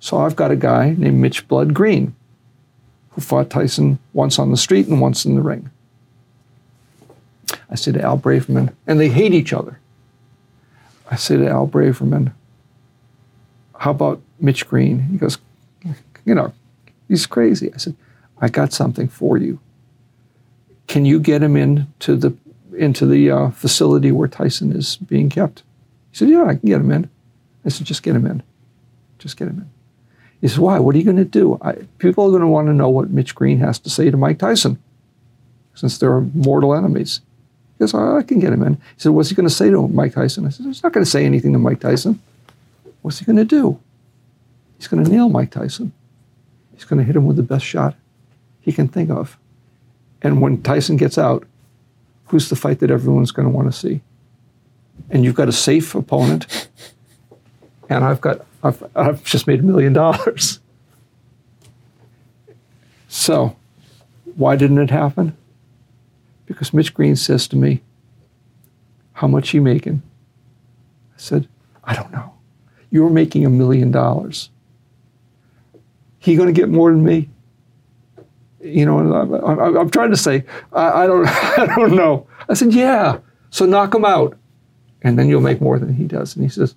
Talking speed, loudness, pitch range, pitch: 185 wpm, -16 LUFS, 120-145 Hz, 125 Hz